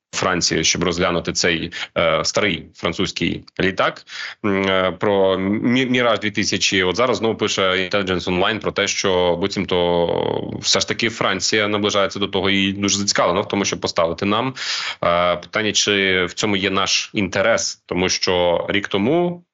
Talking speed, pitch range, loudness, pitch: 155 wpm, 90-105 Hz, -18 LUFS, 100 Hz